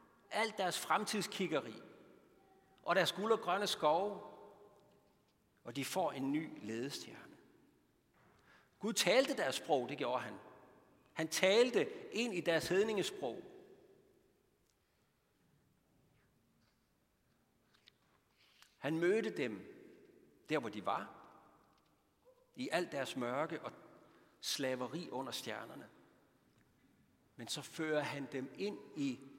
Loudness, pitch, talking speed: -38 LUFS, 190 Hz, 100 wpm